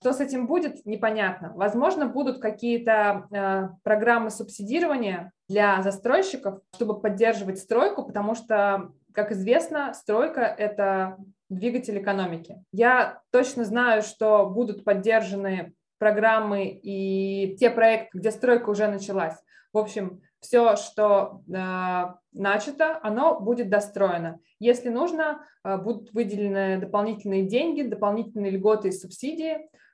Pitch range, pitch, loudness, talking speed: 195-240 Hz, 215 Hz, -25 LUFS, 115 wpm